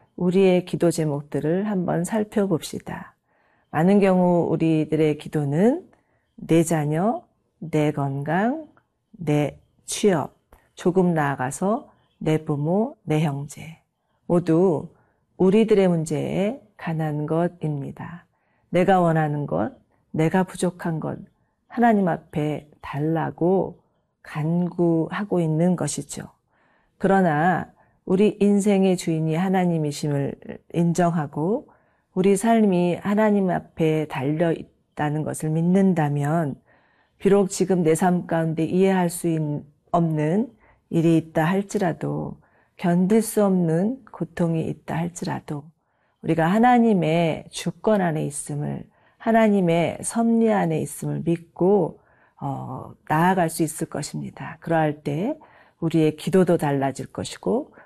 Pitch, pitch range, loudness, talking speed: 170 Hz, 155-190 Hz, -22 LUFS, 235 characters per minute